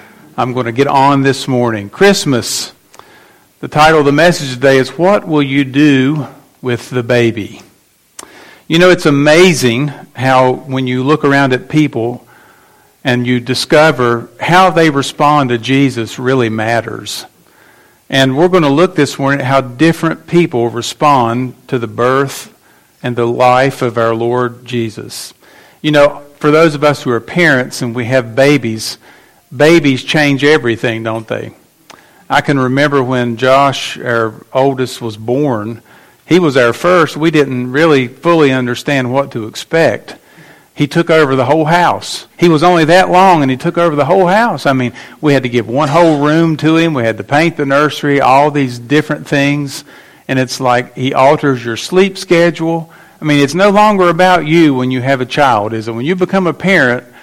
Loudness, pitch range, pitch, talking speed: -11 LUFS, 125-155 Hz, 140 Hz, 180 wpm